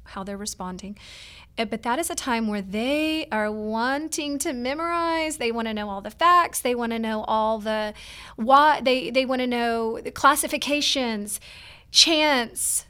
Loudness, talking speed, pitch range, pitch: -23 LUFS, 170 wpm, 215-290 Hz, 240 Hz